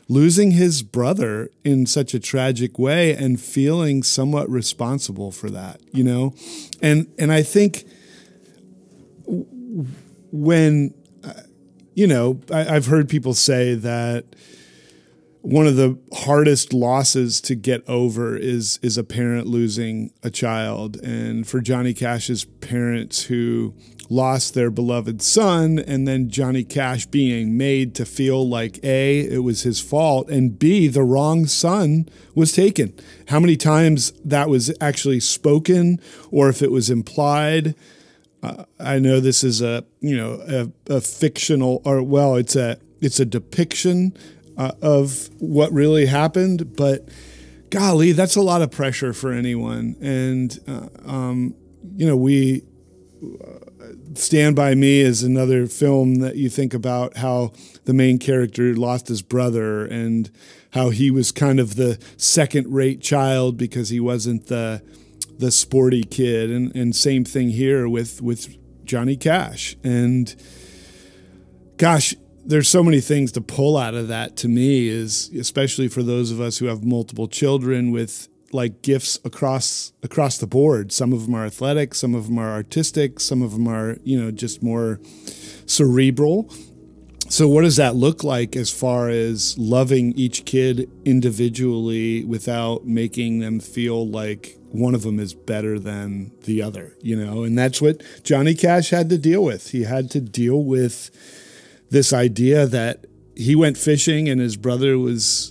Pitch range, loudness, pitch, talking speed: 115-145 Hz, -19 LUFS, 125 Hz, 155 wpm